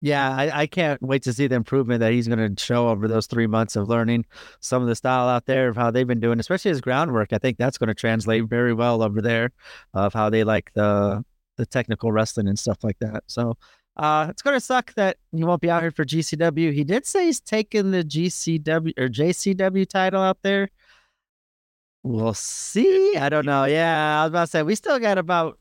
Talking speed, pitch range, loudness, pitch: 225 wpm, 115-170 Hz, -22 LUFS, 130 Hz